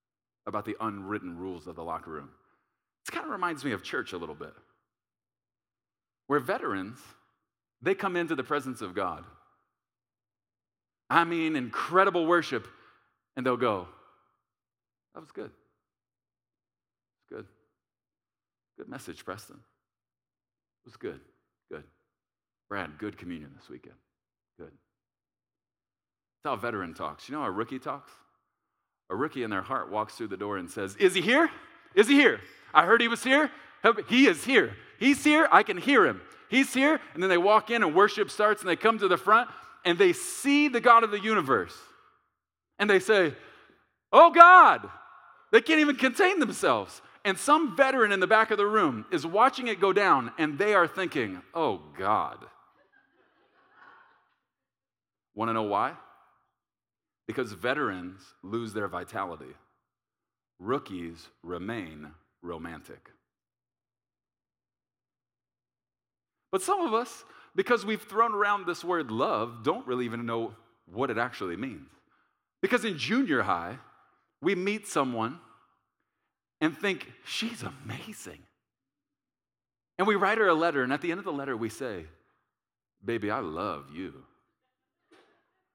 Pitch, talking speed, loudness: 165 Hz, 145 wpm, -25 LUFS